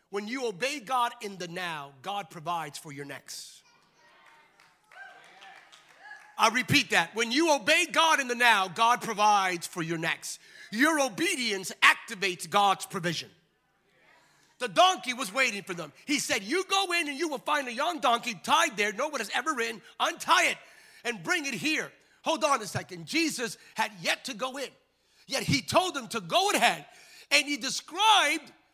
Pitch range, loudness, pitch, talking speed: 200-305 Hz, -27 LUFS, 250 Hz, 175 wpm